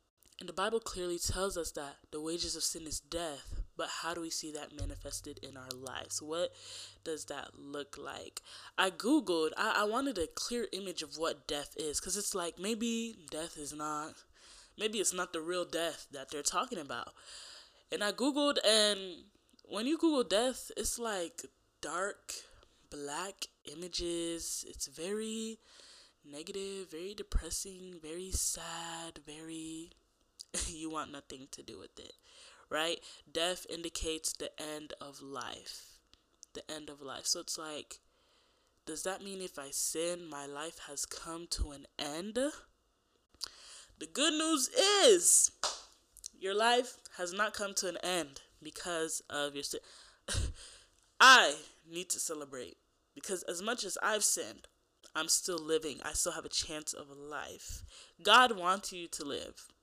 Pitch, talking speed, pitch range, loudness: 170 Hz, 155 wpm, 155-210 Hz, -34 LUFS